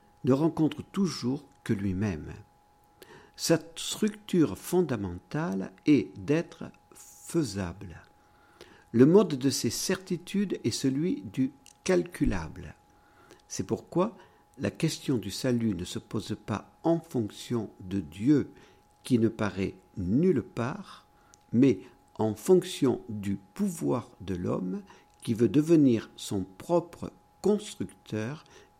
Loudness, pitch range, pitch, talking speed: -29 LUFS, 105-165 Hz, 130 Hz, 110 wpm